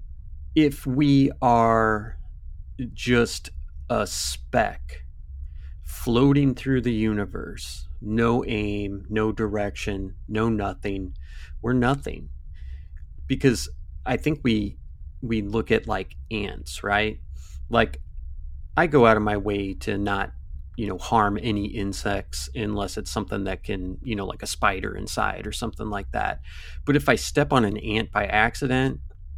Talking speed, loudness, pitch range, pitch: 135 wpm, -24 LUFS, 70-110 Hz, 100 Hz